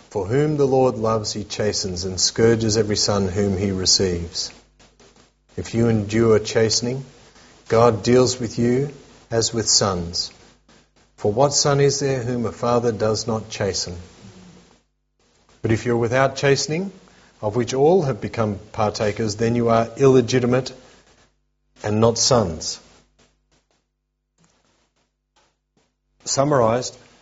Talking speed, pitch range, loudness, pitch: 125 wpm, 105-125 Hz, -20 LUFS, 115 Hz